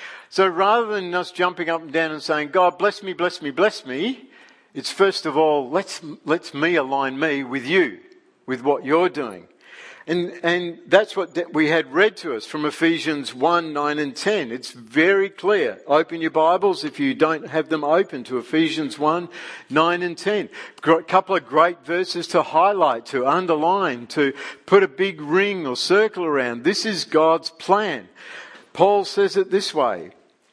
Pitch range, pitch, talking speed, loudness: 155-195 Hz, 170 Hz, 180 wpm, -20 LUFS